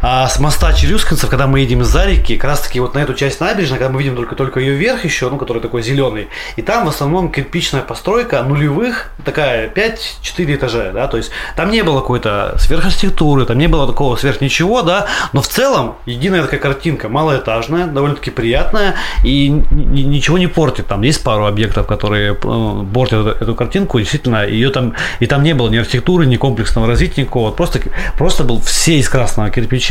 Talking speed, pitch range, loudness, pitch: 195 wpm, 120-155 Hz, -14 LUFS, 135 Hz